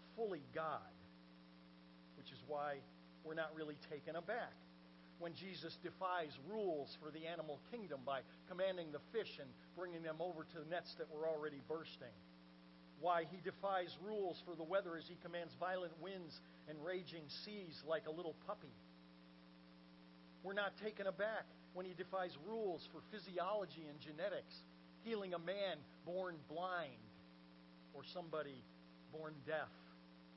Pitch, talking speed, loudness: 160 Hz, 145 wpm, -48 LUFS